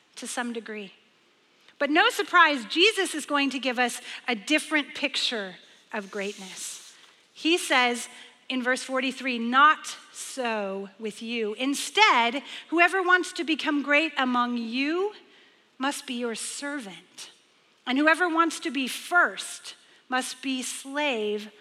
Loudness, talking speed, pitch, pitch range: -25 LUFS, 130 wpm, 265 Hz, 240-310 Hz